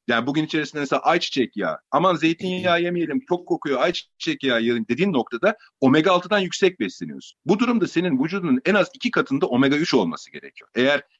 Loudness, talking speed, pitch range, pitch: -21 LUFS, 175 wpm, 155-210 Hz, 180 Hz